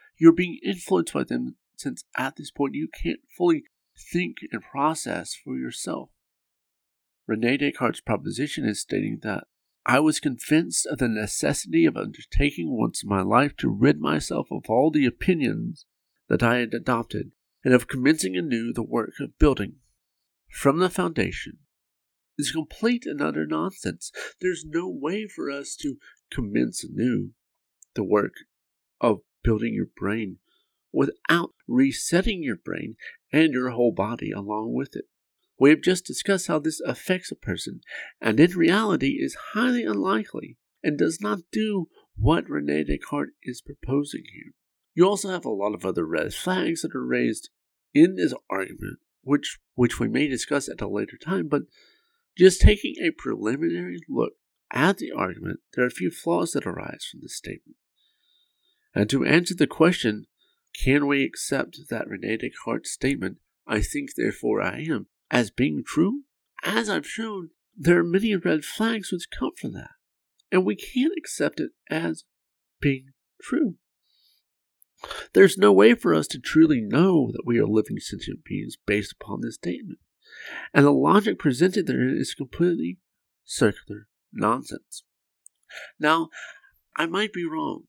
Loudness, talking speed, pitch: -24 LUFS, 155 wpm, 165 Hz